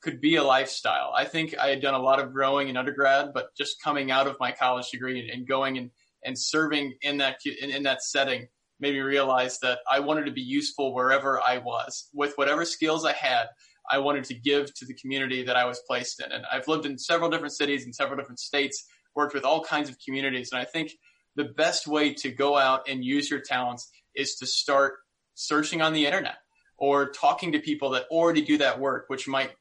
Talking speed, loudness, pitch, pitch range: 225 wpm, -26 LUFS, 140 Hz, 130-150 Hz